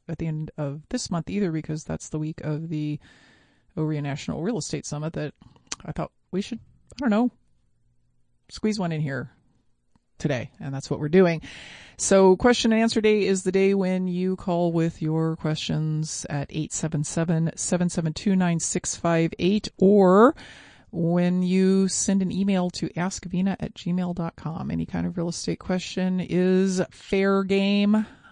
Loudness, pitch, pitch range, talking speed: -24 LUFS, 175 Hz, 155-190 Hz, 155 wpm